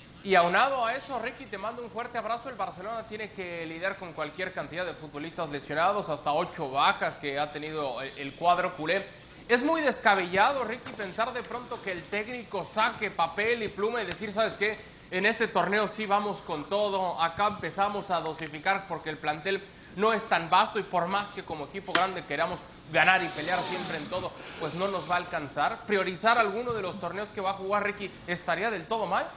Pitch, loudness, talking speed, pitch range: 190 Hz, -29 LUFS, 205 wpm, 170-215 Hz